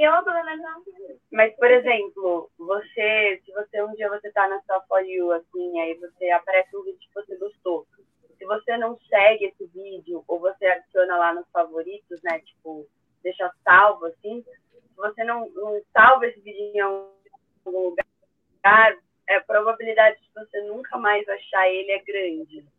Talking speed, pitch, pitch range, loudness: 160 wpm, 205 Hz, 180-225 Hz, -21 LUFS